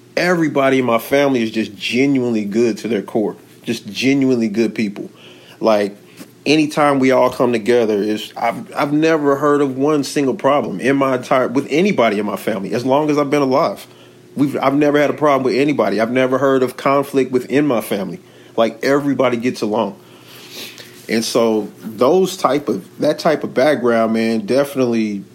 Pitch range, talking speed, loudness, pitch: 110-140 Hz, 180 wpm, -16 LUFS, 130 Hz